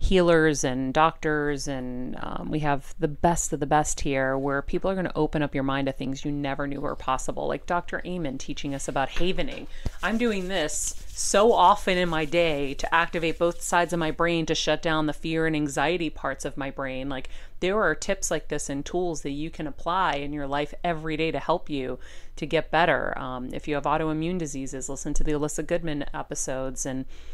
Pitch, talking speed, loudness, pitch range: 150 Hz, 215 wpm, -26 LUFS, 140-165 Hz